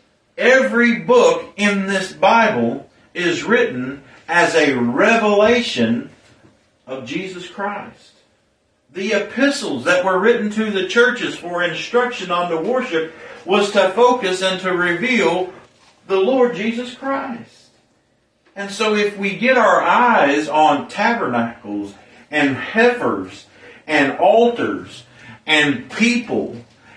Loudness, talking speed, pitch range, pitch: -17 LUFS, 115 wpm, 165-240 Hz, 200 Hz